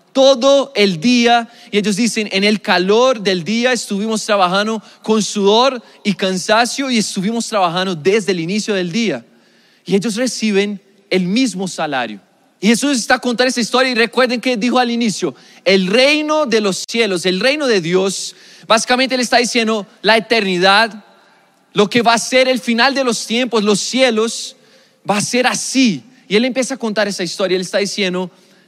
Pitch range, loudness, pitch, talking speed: 195-250 Hz, -15 LUFS, 220 Hz, 180 wpm